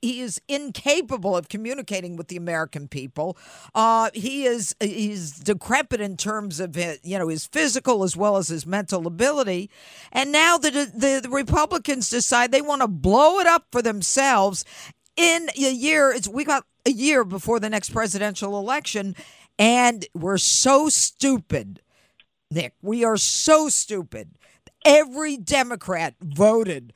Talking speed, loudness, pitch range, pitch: 155 wpm, -21 LUFS, 190-270 Hz, 225 Hz